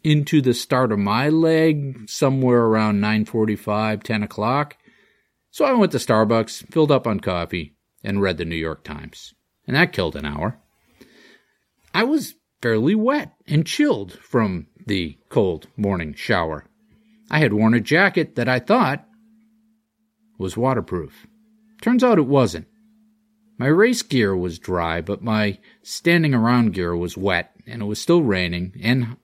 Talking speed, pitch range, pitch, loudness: 150 wpm, 105-170 Hz, 125 Hz, -20 LUFS